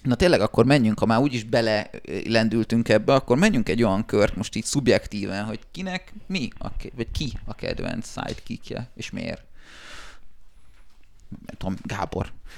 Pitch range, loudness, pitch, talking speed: 105-135 Hz, -24 LUFS, 110 Hz, 155 wpm